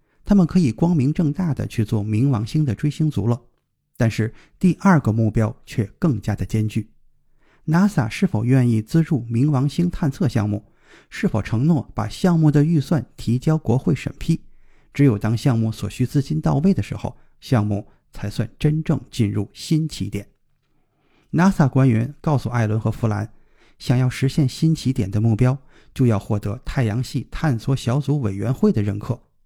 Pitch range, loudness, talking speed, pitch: 110-150 Hz, -21 LUFS, 265 characters per minute, 130 Hz